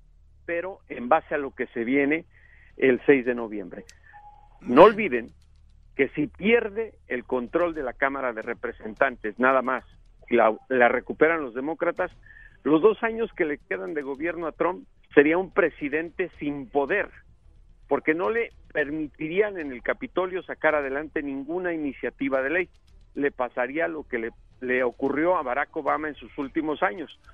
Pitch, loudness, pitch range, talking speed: 145 Hz, -25 LUFS, 125-170 Hz, 160 wpm